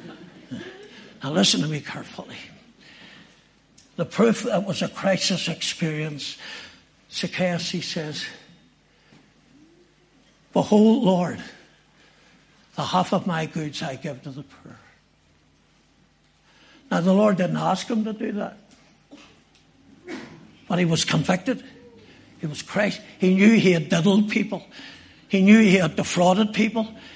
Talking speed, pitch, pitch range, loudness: 120 wpm, 185 Hz, 170-220 Hz, -22 LUFS